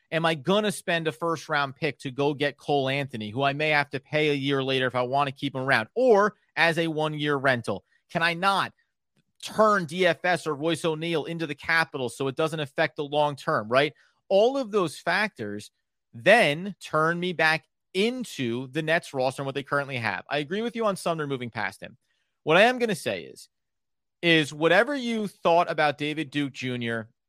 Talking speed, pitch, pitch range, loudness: 205 wpm, 155 Hz, 140-170 Hz, -25 LUFS